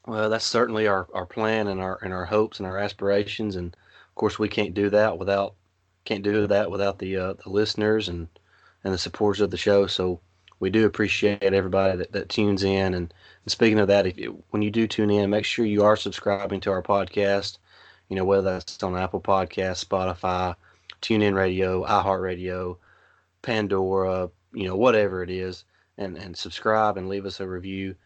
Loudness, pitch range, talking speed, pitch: -24 LUFS, 95-105 Hz, 195 wpm, 100 Hz